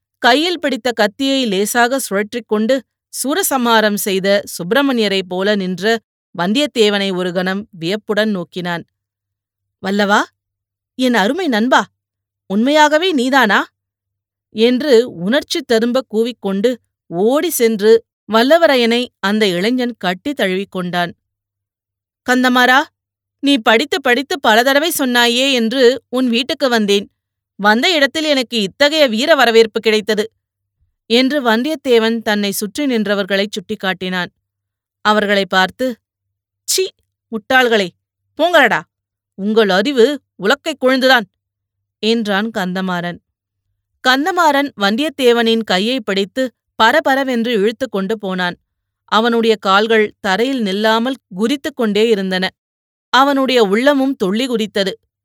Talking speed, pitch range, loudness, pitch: 90 wpm, 185-255 Hz, -15 LUFS, 220 Hz